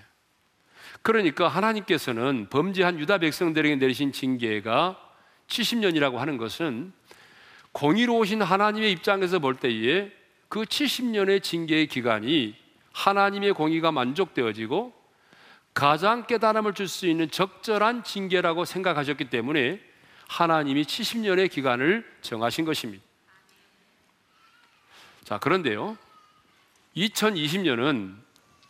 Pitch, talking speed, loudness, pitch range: 185 Hz, 250 characters per minute, -25 LUFS, 150-215 Hz